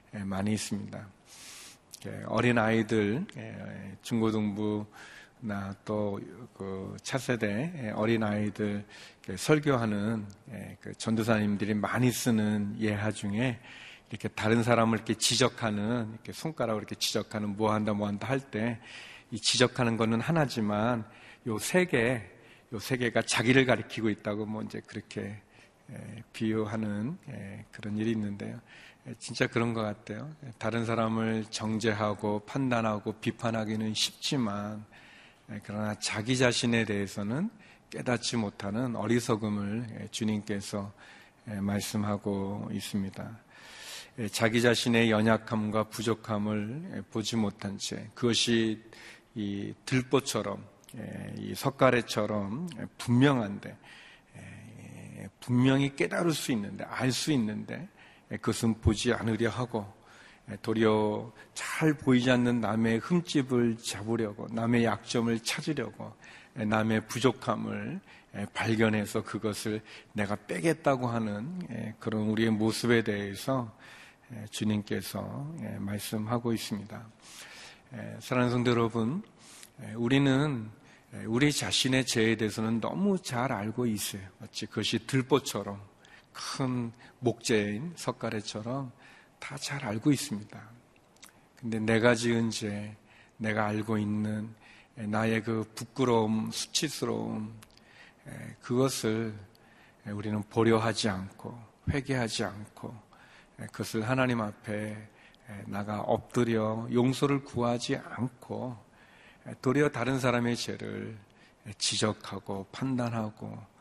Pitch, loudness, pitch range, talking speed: 110 Hz, -30 LUFS, 105-120 Hz, 245 characters per minute